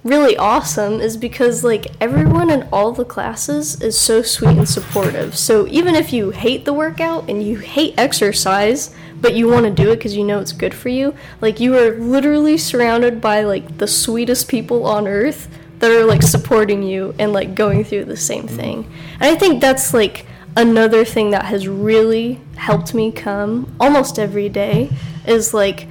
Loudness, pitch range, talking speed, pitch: -15 LUFS, 205-245 Hz, 190 wpm, 225 Hz